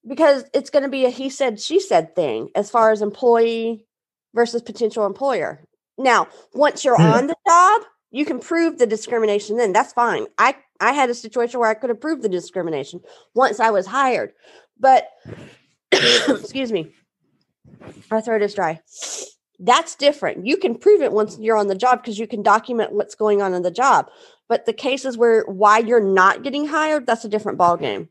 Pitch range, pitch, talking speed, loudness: 215-275 Hz, 235 Hz, 190 wpm, -18 LUFS